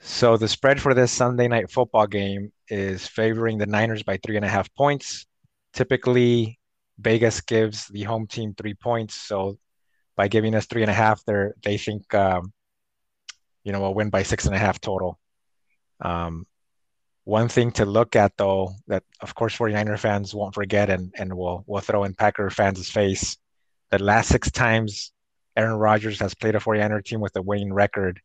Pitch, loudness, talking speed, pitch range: 105 Hz, -23 LUFS, 185 wpm, 100-115 Hz